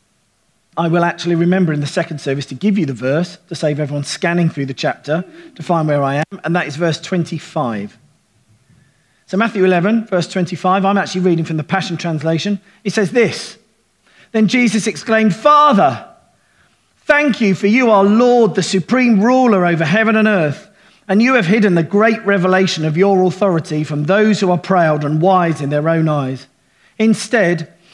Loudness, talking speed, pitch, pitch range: -15 LUFS, 180 wpm, 180 Hz, 155-205 Hz